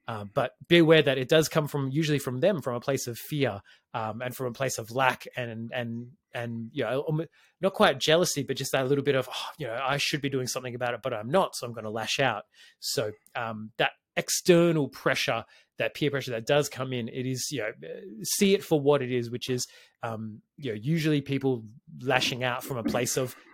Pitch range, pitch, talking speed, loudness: 120-150 Hz, 130 Hz, 235 wpm, -28 LUFS